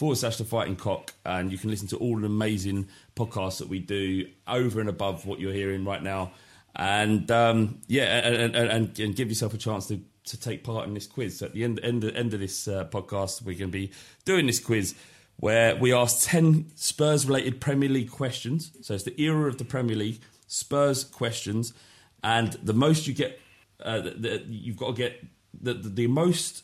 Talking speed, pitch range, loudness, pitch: 215 wpm, 100-125 Hz, -27 LUFS, 115 Hz